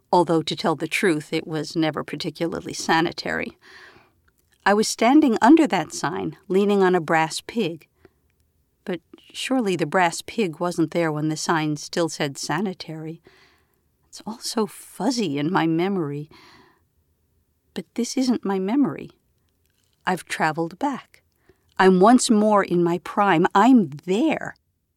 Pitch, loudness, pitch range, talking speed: 175 Hz, -21 LUFS, 160-205 Hz, 135 wpm